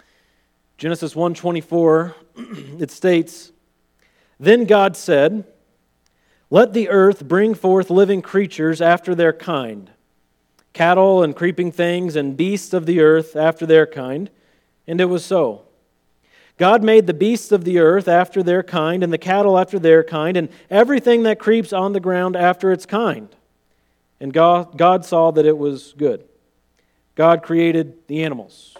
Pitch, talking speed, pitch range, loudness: 170 Hz, 150 wpm, 155-185 Hz, -16 LUFS